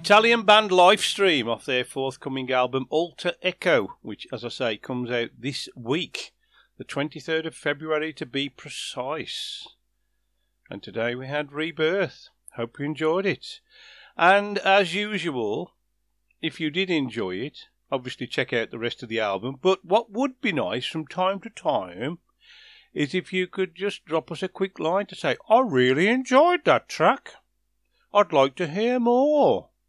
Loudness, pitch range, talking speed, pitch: -24 LUFS, 140-200 Hz, 160 wpm, 170 Hz